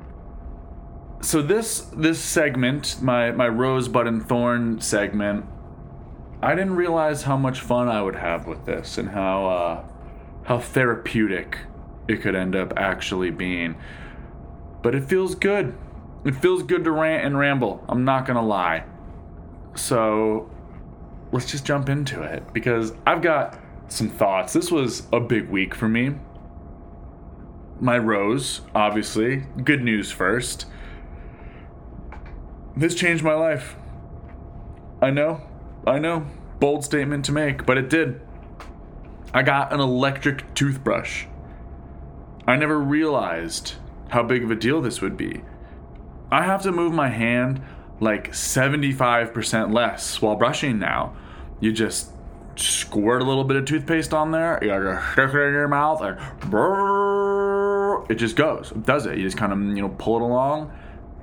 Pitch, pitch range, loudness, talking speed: 115 Hz, 85-140 Hz, -22 LUFS, 140 wpm